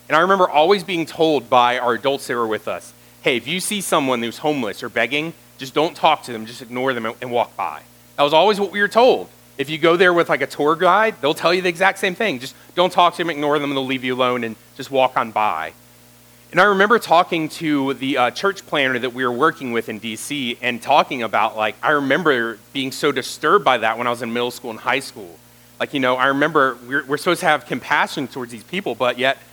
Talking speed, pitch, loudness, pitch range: 255 wpm, 135 Hz, -19 LUFS, 120-165 Hz